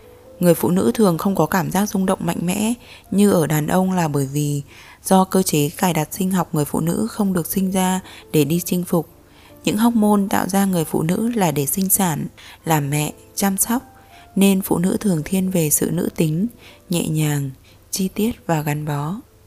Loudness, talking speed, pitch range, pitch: -19 LUFS, 215 wpm, 155-195 Hz, 185 Hz